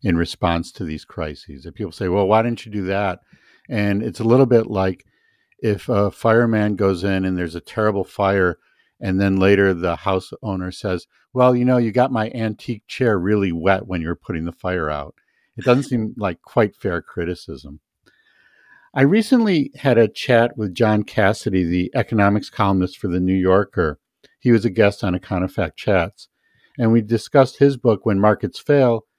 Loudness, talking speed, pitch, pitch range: -19 LUFS, 185 wpm, 105 Hz, 95-115 Hz